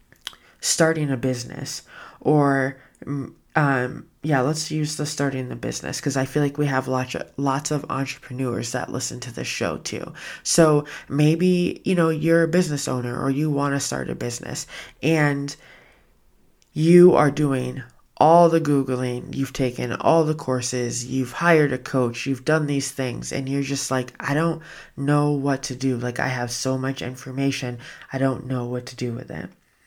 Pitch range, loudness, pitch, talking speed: 130-150 Hz, -22 LUFS, 135 Hz, 175 wpm